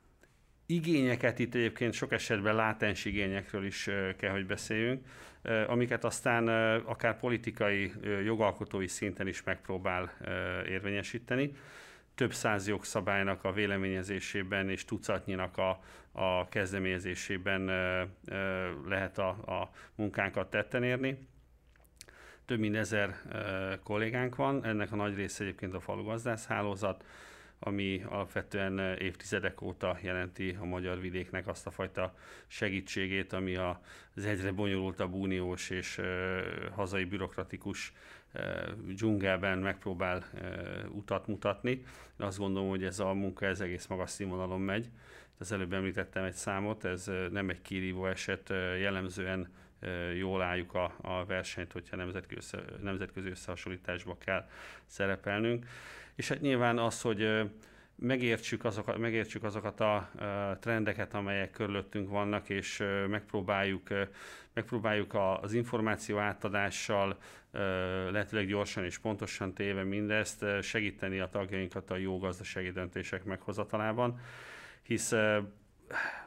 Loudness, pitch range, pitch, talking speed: -35 LUFS, 95-110 Hz, 100 Hz, 115 wpm